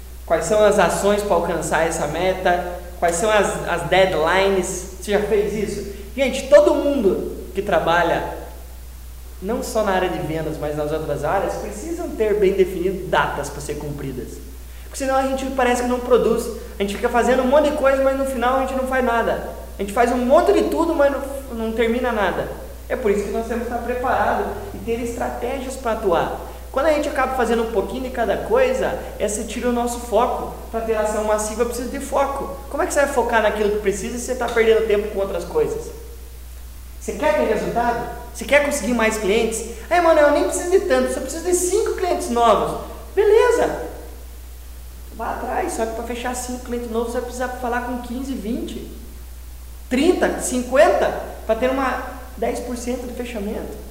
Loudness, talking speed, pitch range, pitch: -20 LUFS, 200 wpm, 195-260 Hz, 230 Hz